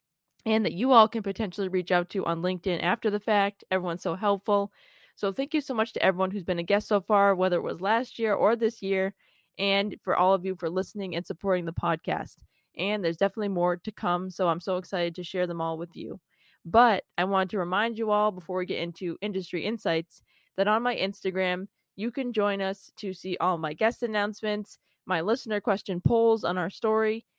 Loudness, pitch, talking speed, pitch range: -27 LUFS, 195 Hz, 215 wpm, 180-215 Hz